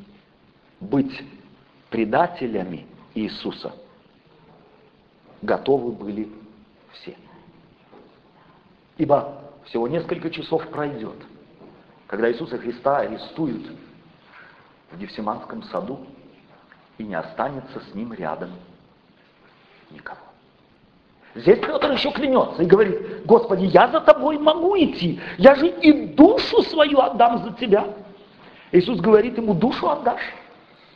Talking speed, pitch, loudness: 95 wpm, 190 Hz, -20 LUFS